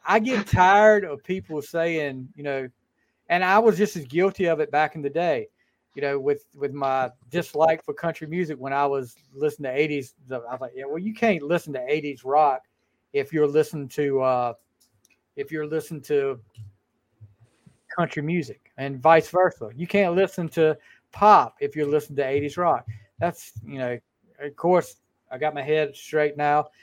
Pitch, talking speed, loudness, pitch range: 150 Hz, 185 wpm, -24 LUFS, 135-170 Hz